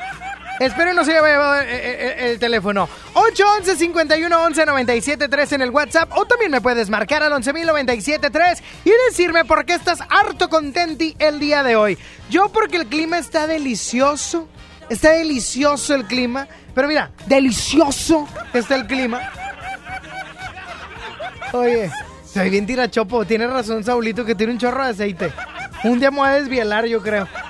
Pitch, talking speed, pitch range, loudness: 285 Hz, 150 wpm, 245-325 Hz, -17 LUFS